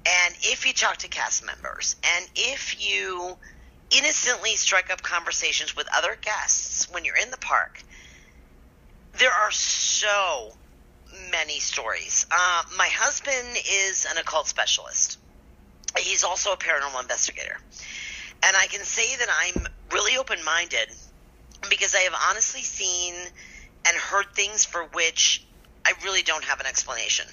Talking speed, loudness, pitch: 140 wpm, -23 LUFS, 180 Hz